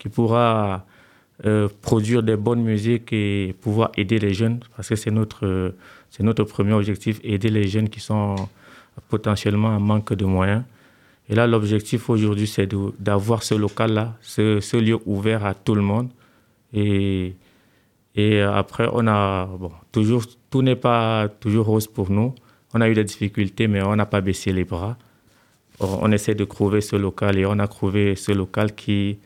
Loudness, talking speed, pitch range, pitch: -21 LUFS, 180 wpm, 100-115 Hz, 105 Hz